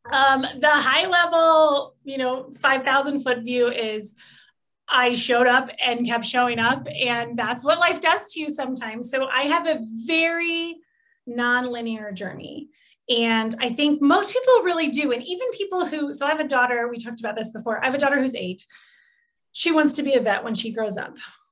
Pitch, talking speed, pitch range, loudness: 265 Hz, 190 wpm, 240-315 Hz, -21 LUFS